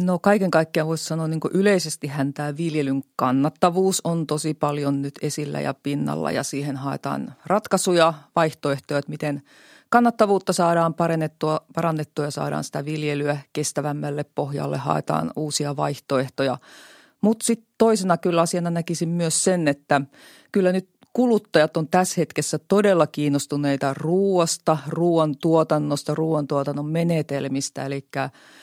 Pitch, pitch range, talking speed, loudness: 155 Hz, 145-175 Hz, 125 wpm, -22 LUFS